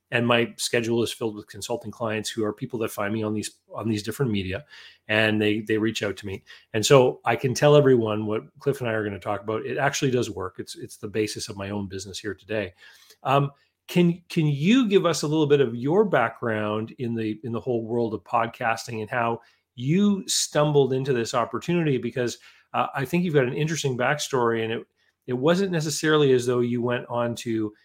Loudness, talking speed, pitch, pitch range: -24 LUFS, 220 wpm, 120 Hz, 110-140 Hz